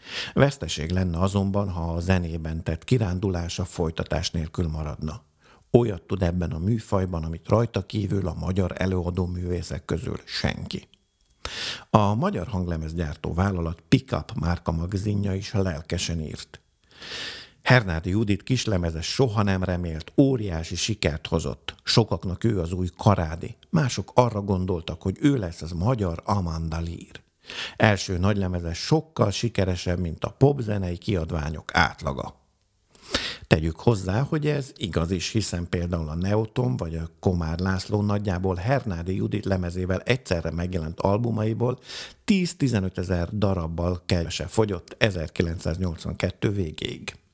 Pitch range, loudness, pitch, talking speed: 85-105 Hz, -26 LUFS, 95 Hz, 120 wpm